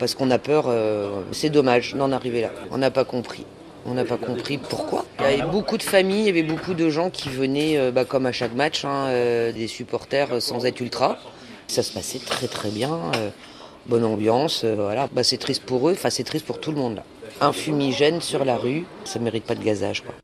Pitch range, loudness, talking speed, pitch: 120-145 Hz, -23 LUFS, 215 wpm, 130 Hz